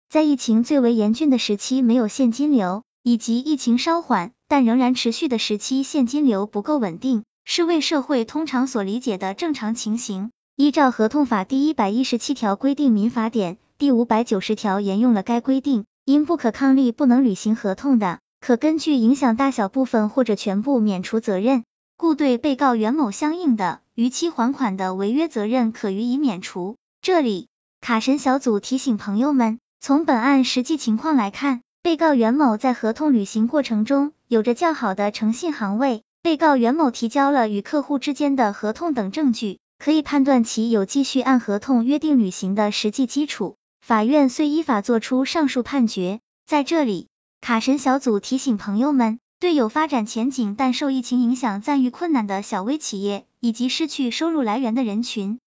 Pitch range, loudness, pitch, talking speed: 220-280 Hz, -20 LUFS, 250 Hz, 285 characters per minute